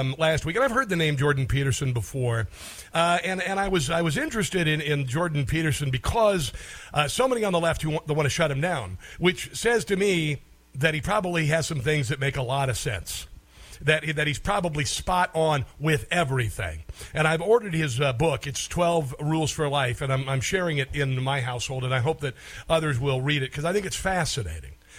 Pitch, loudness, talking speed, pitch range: 150 Hz, -25 LUFS, 225 wpm, 130-170 Hz